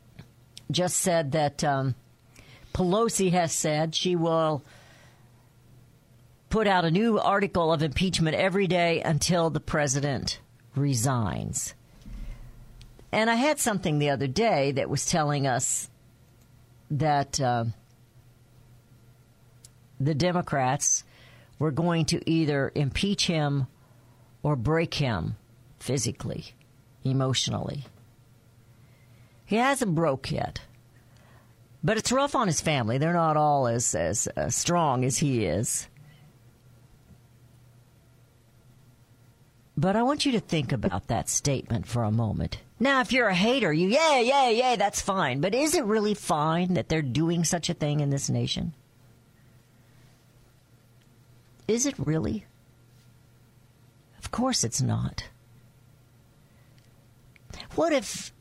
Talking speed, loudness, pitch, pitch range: 115 wpm, -26 LUFS, 130 Hz, 120-165 Hz